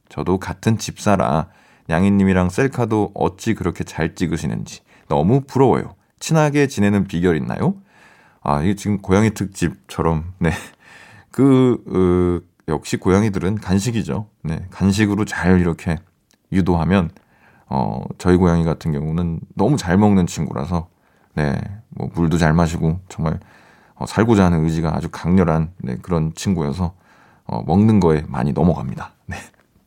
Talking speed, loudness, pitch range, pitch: 295 characters per minute, -19 LUFS, 85-105 Hz, 90 Hz